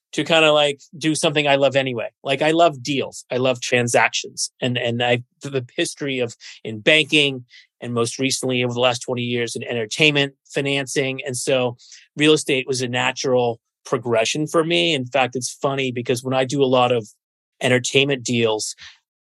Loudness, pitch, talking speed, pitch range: -20 LUFS, 130 Hz, 180 wpm, 125-145 Hz